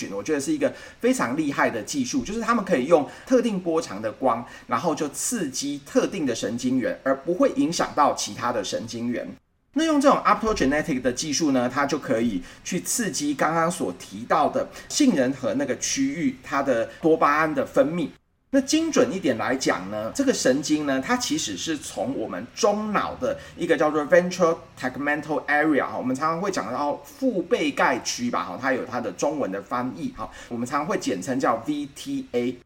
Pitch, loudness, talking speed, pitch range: 250 Hz, -24 LUFS, 325 characters per minute, 165-275 Hz